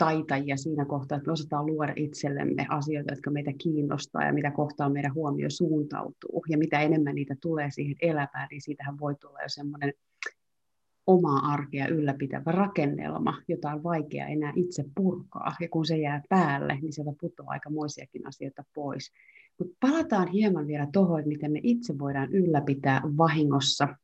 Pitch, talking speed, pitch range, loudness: 150 Hz, 160 wpm, 145-165 Hz, -29 LUFS